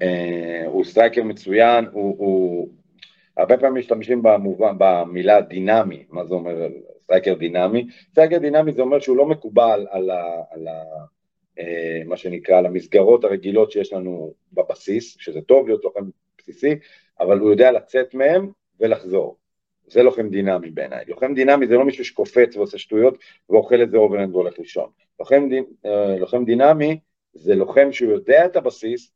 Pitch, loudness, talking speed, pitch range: 120 Hz, -18 LUFS, 155 wpm, 95-155 Hz